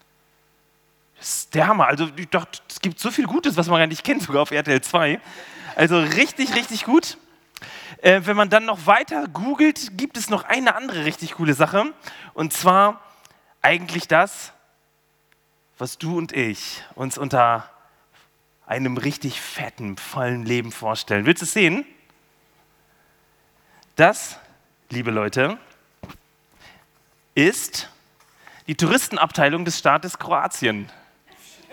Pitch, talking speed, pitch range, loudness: 170 Hz, 120 wpm, 140-205 Hz, -20 LUFS